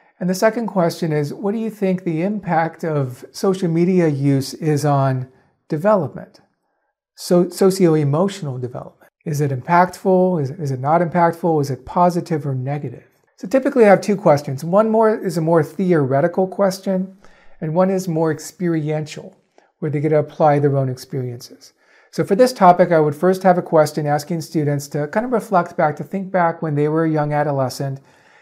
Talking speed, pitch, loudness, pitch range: 180 wpm, 165 Hz, -18 LUFS, 150-185 Hz